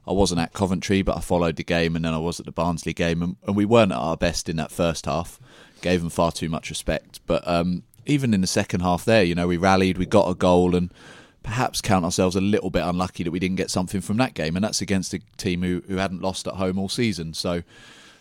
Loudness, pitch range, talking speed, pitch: -23 LUFS, 85-95 Hz, 265 wpm, 90 Hz